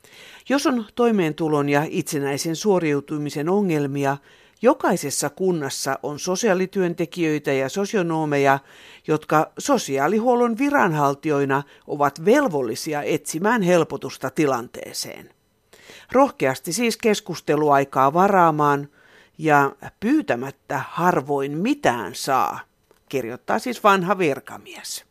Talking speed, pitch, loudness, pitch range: 80 wpm, 160 Hz, -21 LUFS, 145-205 Hz